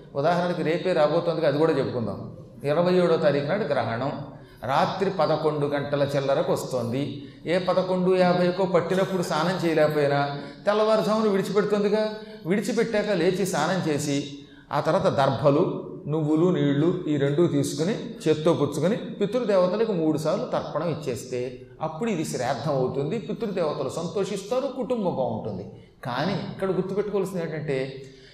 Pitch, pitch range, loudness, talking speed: 165 Hz, 140-195 Hz, -25 LUFS, 110 wpm